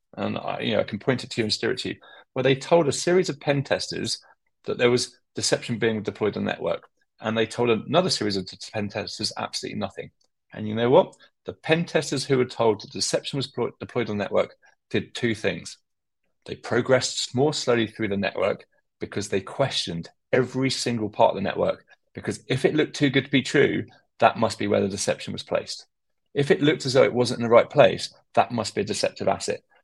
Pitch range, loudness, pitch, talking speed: 110-135 Hz, -24 LUFS, 120 Hz, 230 wpm